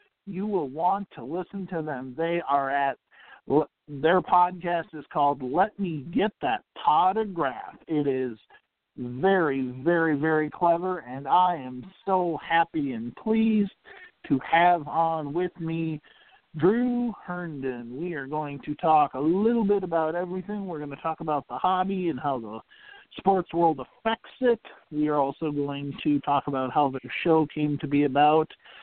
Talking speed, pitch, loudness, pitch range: 160 wpm, 165 Hz, -26 LUFS, 145-190 Hz